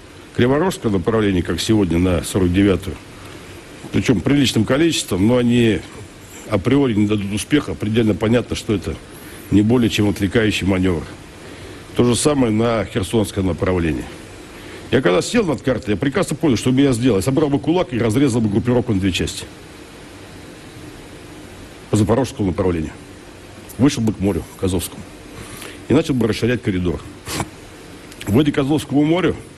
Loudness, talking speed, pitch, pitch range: -18 LUFS, 145 wpm, 105 Hz, 95-125 Hz